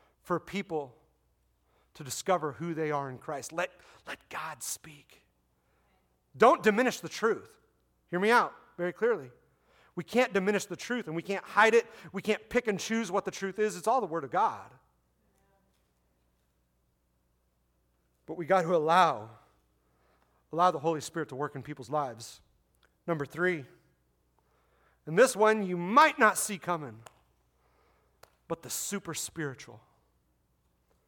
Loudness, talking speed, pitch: -29 LUFS, 145 wpm, 150 Hz